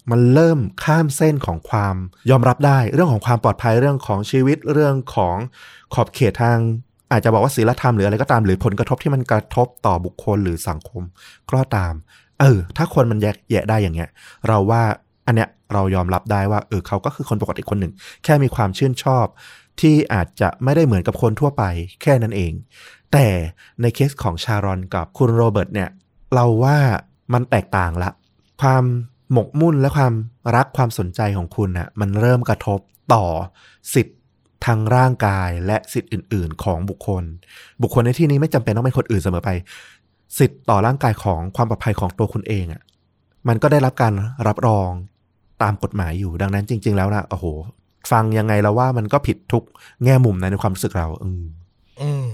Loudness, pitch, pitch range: -18 LUFS, 110 Hz, 95-125 Hz